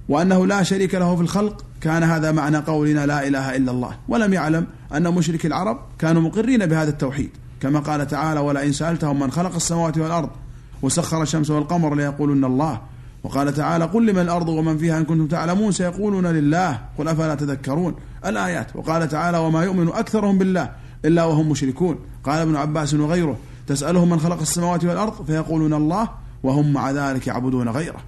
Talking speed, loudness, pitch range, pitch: 170 wpm, -20 LUFS, 140-170 Hz, 155 Hz